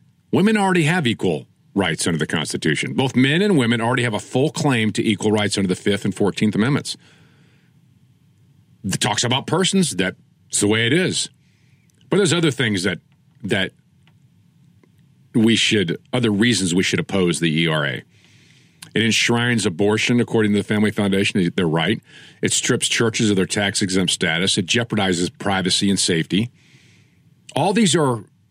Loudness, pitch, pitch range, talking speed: -19 LUFS, 110 Hz, 100-140 Hz, 160 wpm